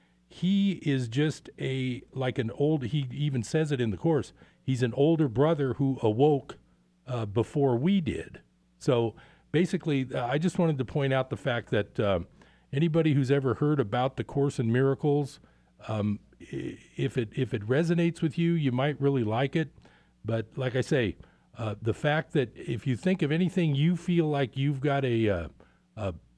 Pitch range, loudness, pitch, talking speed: 115-150 Hz, -28 LUFS, 135 Hz, 180 wpm